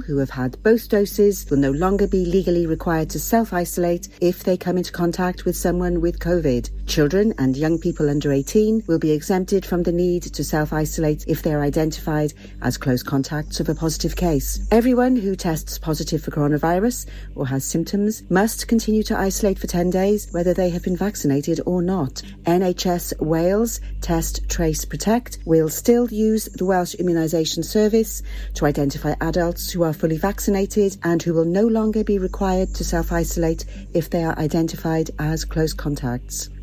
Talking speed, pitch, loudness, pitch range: 175 wpm, 170 Hz, -21 LUFS, 155-190 Hz